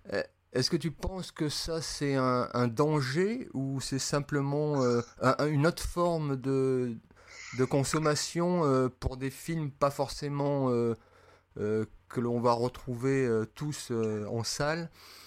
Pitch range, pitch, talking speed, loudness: 125-150 Hz, 135 Hz, 150 wpm, -31 LUFS